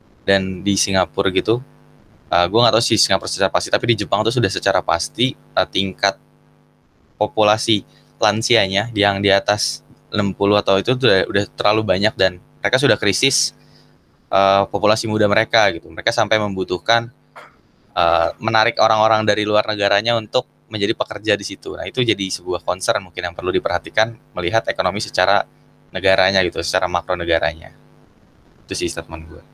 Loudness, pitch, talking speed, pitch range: -18 LUFS, 100 Hz, 155 wpm, 95-110 Hz